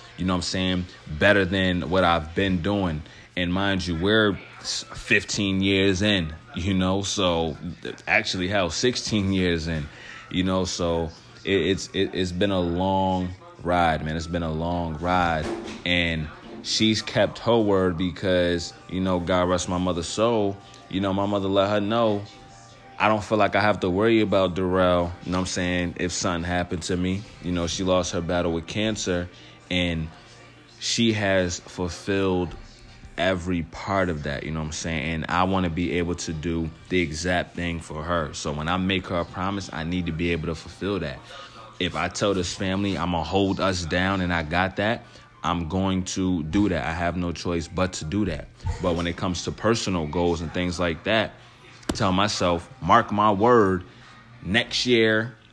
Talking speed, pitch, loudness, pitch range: 190 wpm, 90 Hz, -24 LUFS, 85-100 Hz